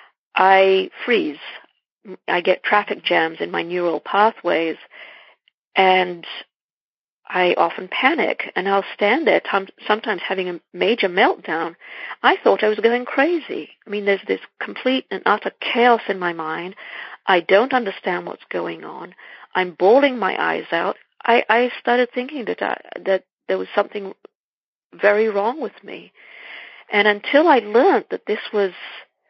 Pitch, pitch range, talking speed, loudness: 205 Hz, 185-235 Hz, 150 wpm, -19 LUFS